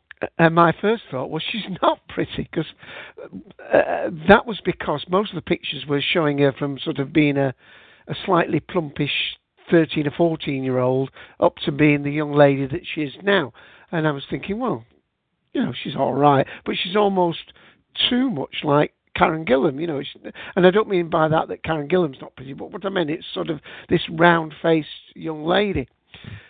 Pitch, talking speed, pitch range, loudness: 160 Hz, 195 wpm, 145-180 Hz, -21 LUFS